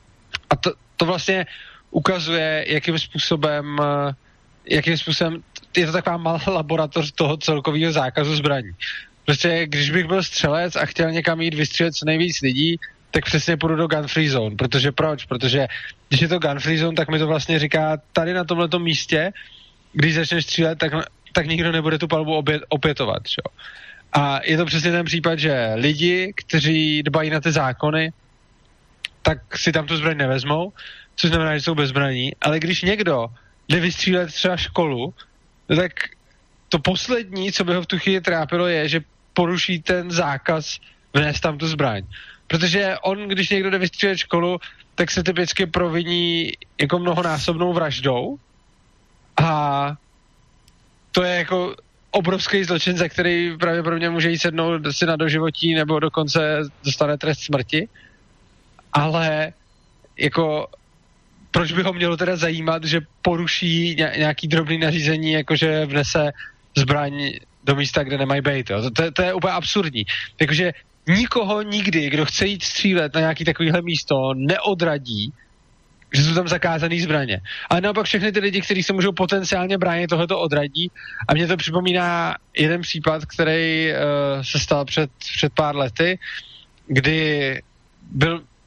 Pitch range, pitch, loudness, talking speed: 150-175 Hz, 160 Hz, -20 LUFS, 150 wpm